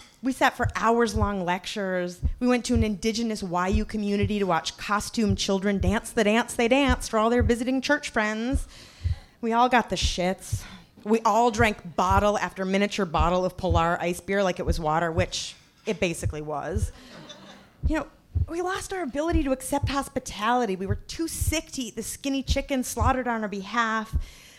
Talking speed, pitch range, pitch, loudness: 180 wpm, 190-250 Hz, 220 Hz, -26 LUFS